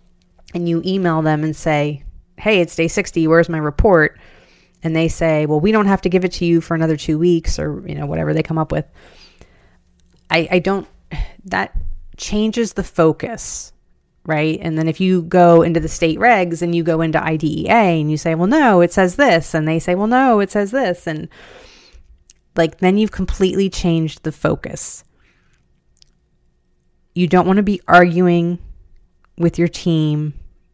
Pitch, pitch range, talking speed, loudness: 165 Hz, 155-180 Hz, 180 wpm, -16 LUFS